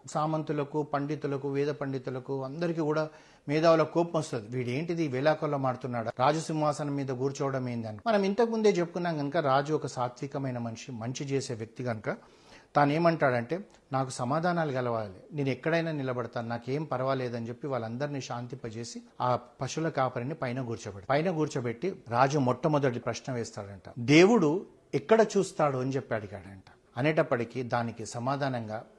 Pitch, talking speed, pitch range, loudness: 135 Hz, 130 wpm, 120-155 Hz, -30 LUFS